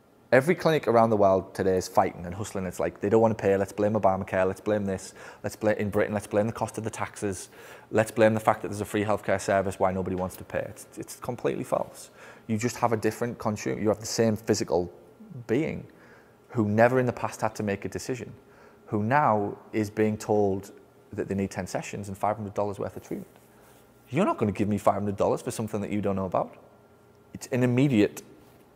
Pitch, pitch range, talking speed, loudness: 105 Hz, 100-115 Hz, 225 wpm, -27 LUFS